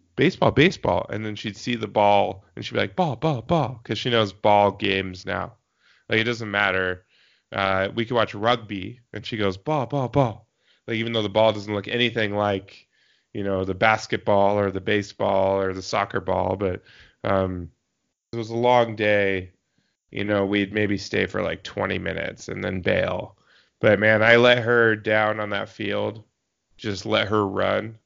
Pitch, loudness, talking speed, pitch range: 105 Hz, -23 LUFS, 190 wpm, 100-115 Hz